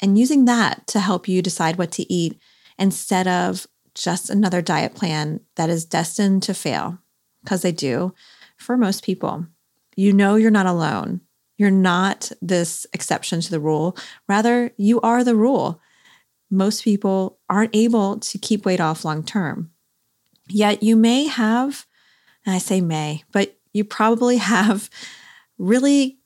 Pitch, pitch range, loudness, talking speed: 195 Hz, 180-220 Hz, -20 LUFS, 155 wpm